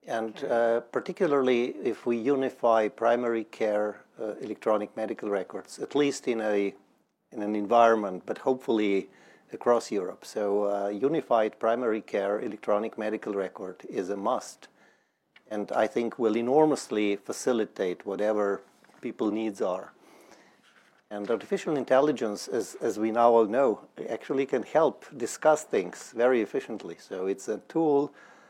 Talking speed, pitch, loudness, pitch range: 135 wpm, 115 Hz, -28 LUFS, 105-130 Hz